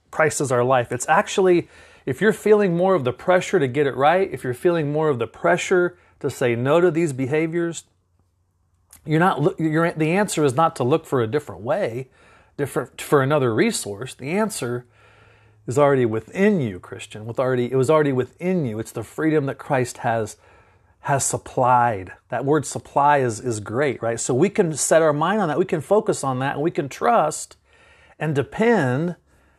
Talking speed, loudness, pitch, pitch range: 195 wpm, -21 LUFS, 145 Hz, 120-170 Hz